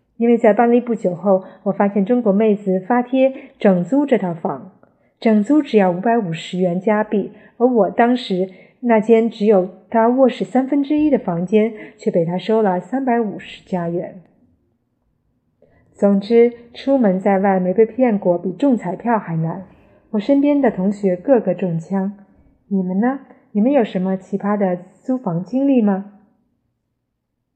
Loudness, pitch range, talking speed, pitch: -17 LUFS, 185-240 Hz, 225 characters per minute, 205 Hz